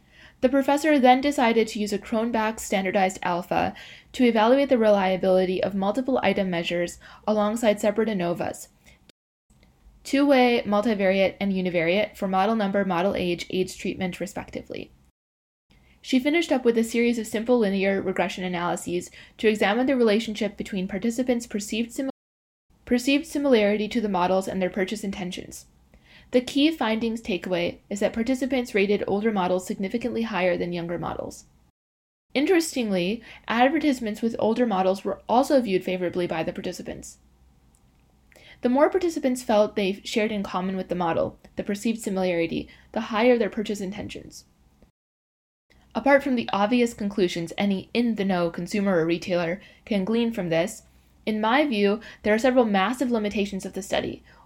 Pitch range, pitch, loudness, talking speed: 185-235 Hz, 205 Hz, -24 LUFS, 150 wpm